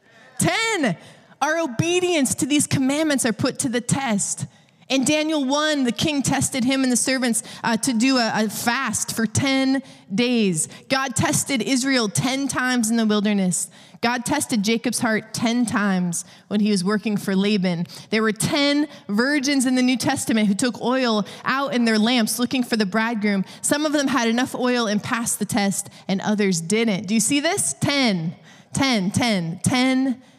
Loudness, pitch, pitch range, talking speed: -21 LUFS, 230 Hz, 205-265 Hz, 180 wpm